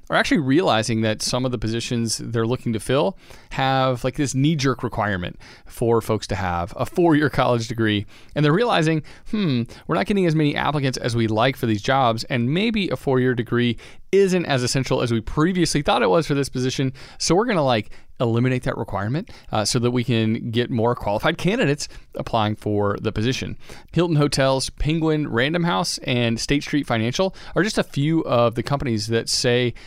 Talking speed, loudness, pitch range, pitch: 200 wpm, -21 LUFS, 115-145 Hz, 125 Hz